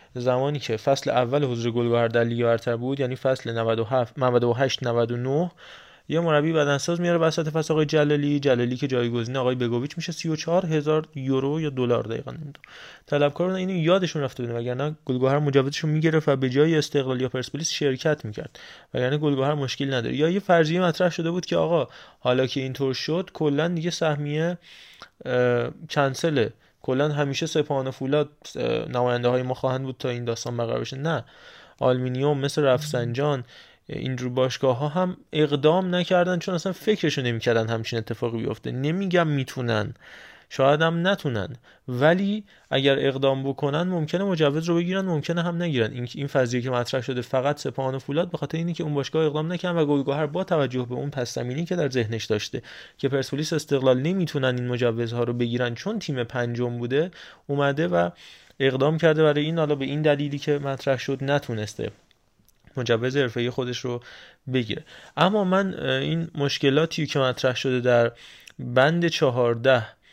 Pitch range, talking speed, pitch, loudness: 125-155 Hz, 165 wpm, 140 Hz, -24 LUFS